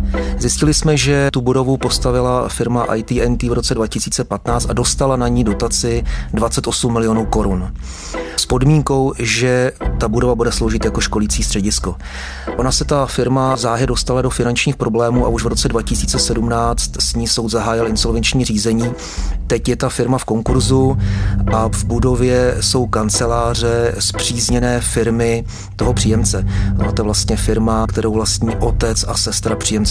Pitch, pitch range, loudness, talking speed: 115 Hz, 105-125 Hz, -16 LUFS, 150 wpm